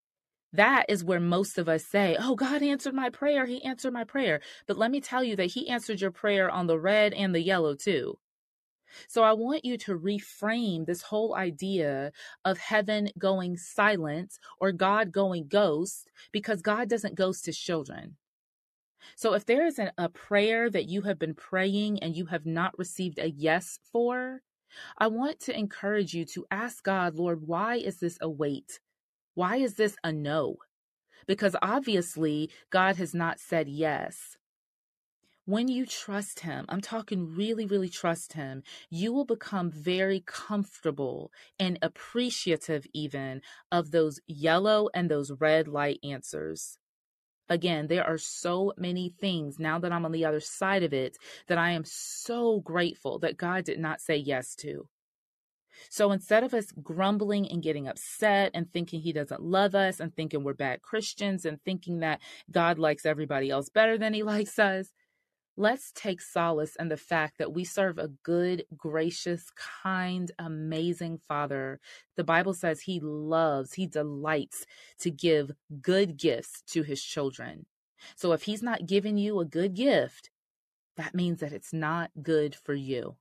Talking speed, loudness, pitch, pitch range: 165 wpm, -29 LUFS, 180 Hz, 160-210 Hz